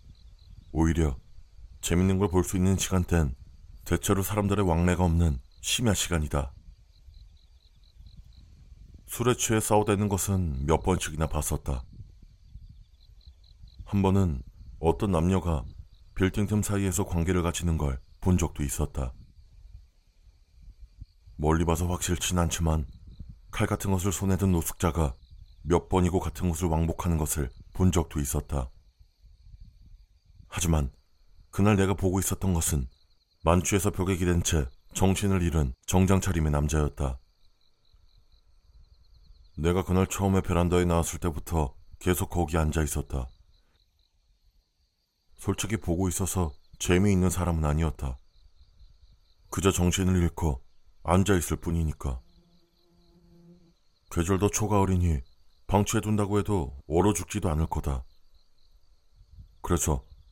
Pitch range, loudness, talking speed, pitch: 75-95 Hz, -27 LUFS, 245 characters per minute, 85 Hz